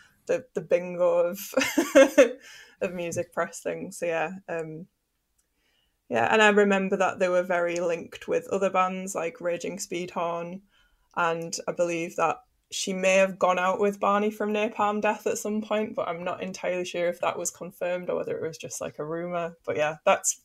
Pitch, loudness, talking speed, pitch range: 185 Hz, -26 LUFS, 185 wpm, 170-210 Hz